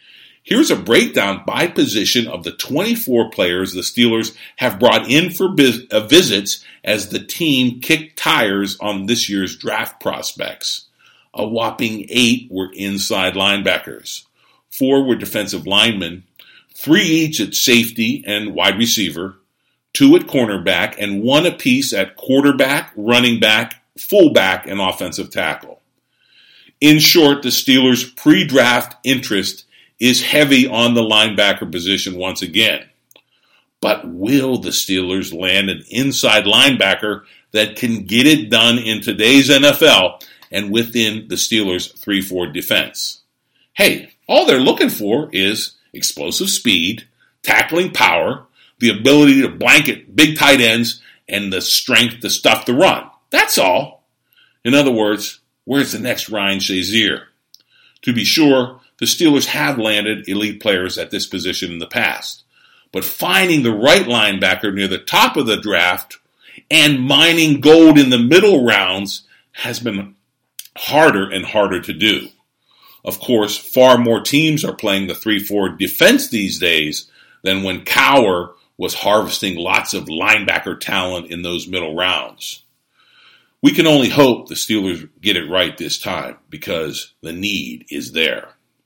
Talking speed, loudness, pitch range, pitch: 140 wpm, -14 LUFS, 100-135 Hz, 115 Hz